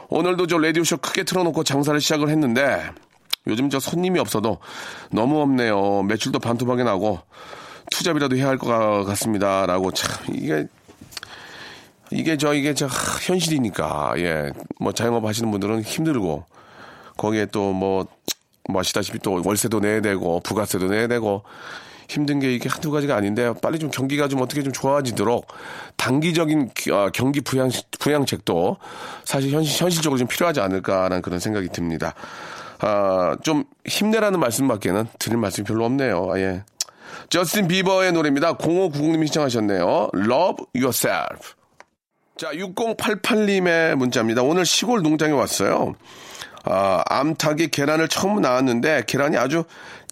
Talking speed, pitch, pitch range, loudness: 320 characters per minute, 130 Hz, 105-160 Hz, -21 LUFS